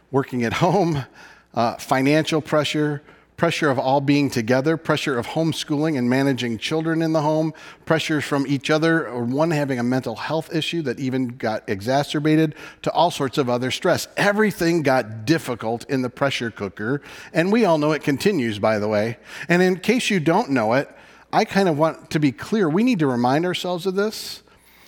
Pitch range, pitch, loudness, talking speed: 130-165 Hz, 150 Hz, -21 LUFS, 190 wpm